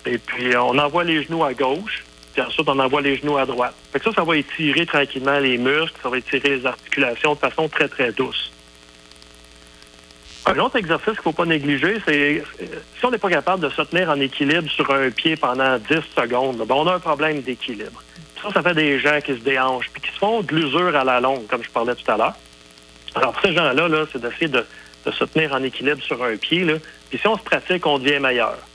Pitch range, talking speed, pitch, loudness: 125-160 Hz, 235 wpm, 145 Hz, -20 LUFS